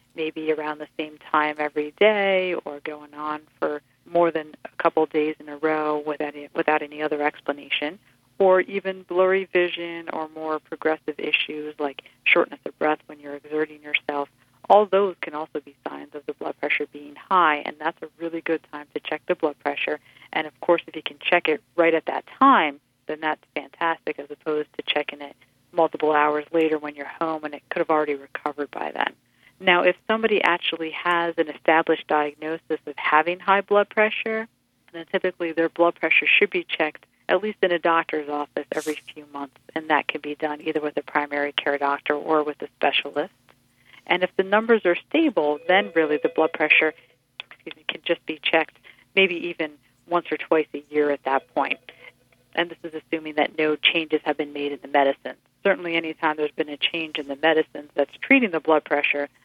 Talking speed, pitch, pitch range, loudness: 200 wpm, 155 Hz, 150-170 Hz, -23 LUFS